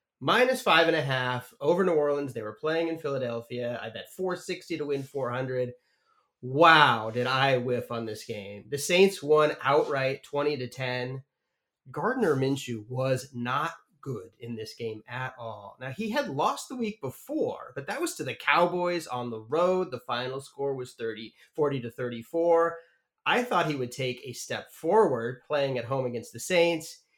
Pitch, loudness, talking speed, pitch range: 135 Hz, -28 LUFS, 180 wpm, 120-165 Hz